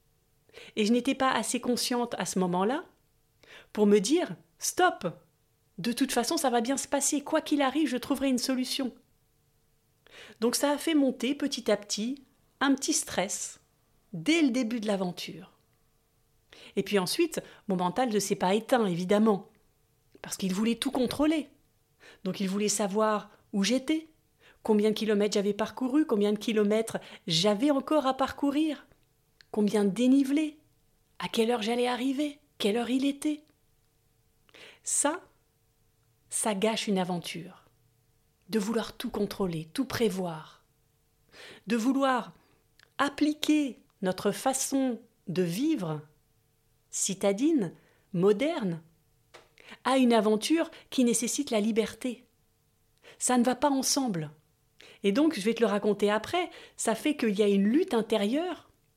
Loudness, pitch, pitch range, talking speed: -28 LUFS, 230 Hz, 200-275 Hz, 140 wpm